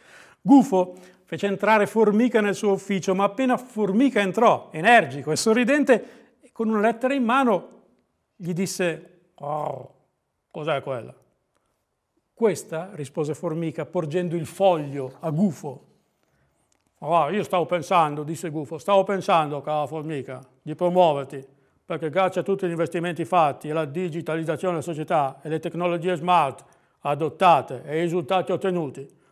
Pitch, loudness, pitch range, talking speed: 175 Hz, -23 LUFS, 155-195 Hz, 135 wpm